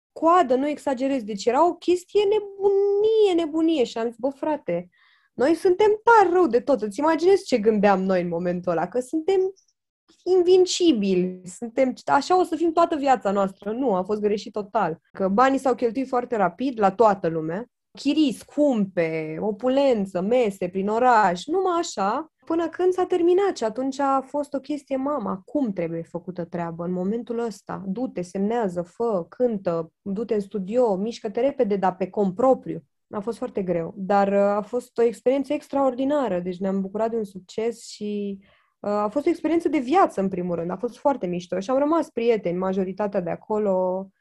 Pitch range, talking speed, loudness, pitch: 195-295 Hz, 175 wpm, -23 LUFS, 235 Hz